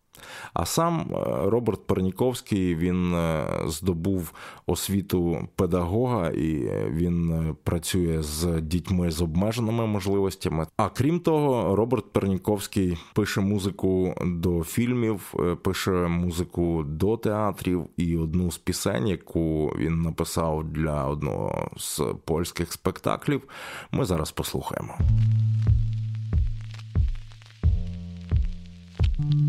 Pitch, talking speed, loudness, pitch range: 90 Hz, 90 wpm, -26 LUFS, 85-110 Hz